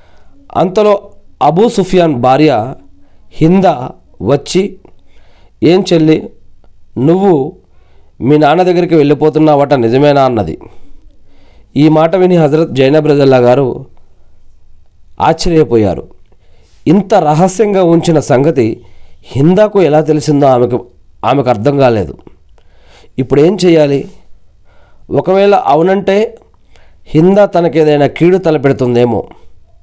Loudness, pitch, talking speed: -9 LUFS, 140 Hz, 85 wpm